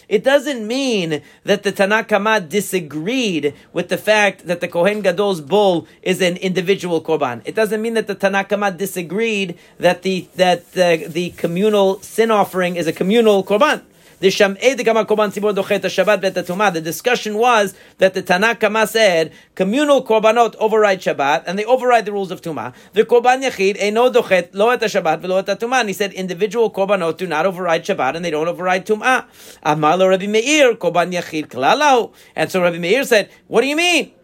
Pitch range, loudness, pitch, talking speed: 180-220 Hz, -17 LUFS, 195 Hz, 160 wpm